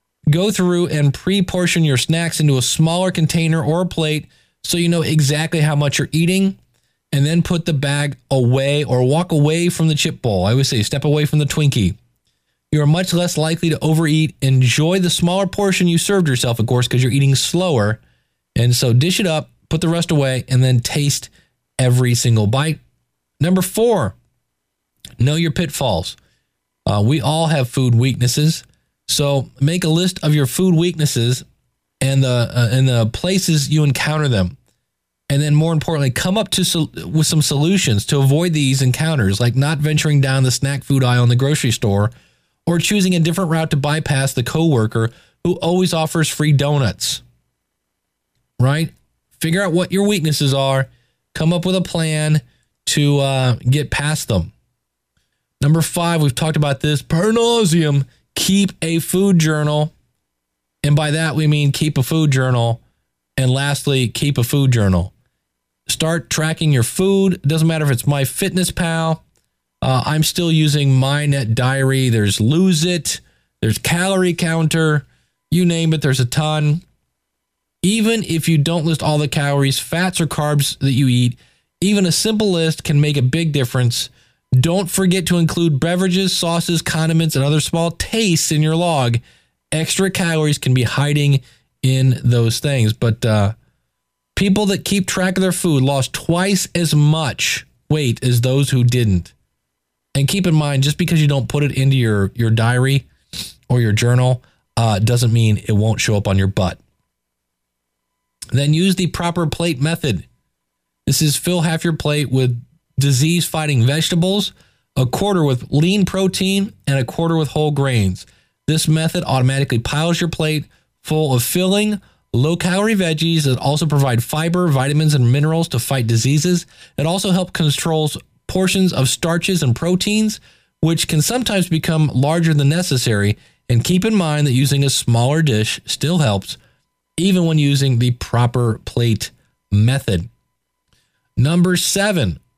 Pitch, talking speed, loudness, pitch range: 150 Hz, 165 wpm, -16 LUFS, 125-165 Hz